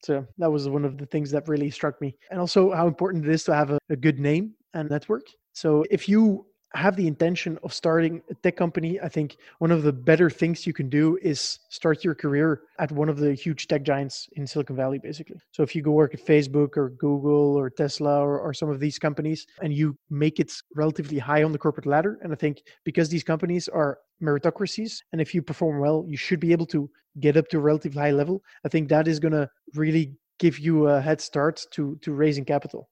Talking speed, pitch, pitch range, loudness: 235 wpm, 155 Hz, 145-165 Hz, -24 LUFS